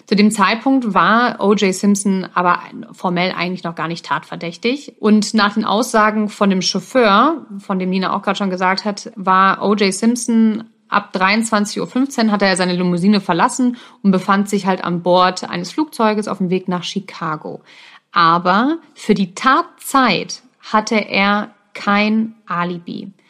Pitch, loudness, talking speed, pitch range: 205 Hz, -16 LUFS, 155 wpm, 185-230 Hz